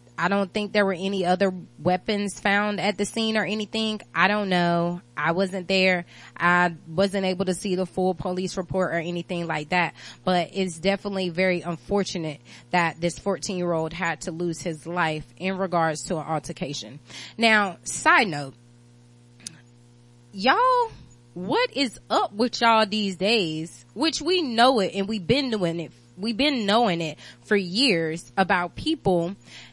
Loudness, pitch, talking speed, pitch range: -24 LUFS, 185 Hz, 165 wpm, 165-205 Hz